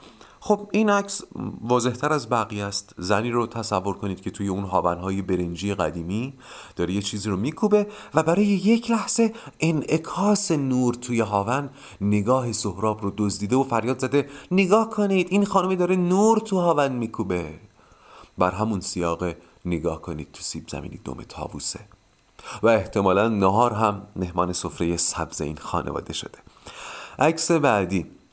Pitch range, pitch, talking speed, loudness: 95-160 Hz, 110 Hz, 145 wpm, -23 LUFS